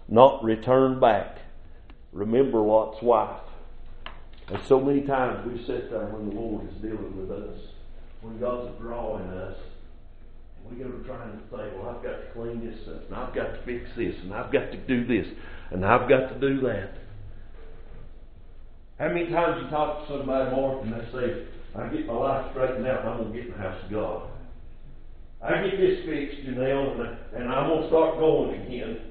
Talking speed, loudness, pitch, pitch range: 200 wpm, -26 LUFS, 120 Hz, 105-135 Hz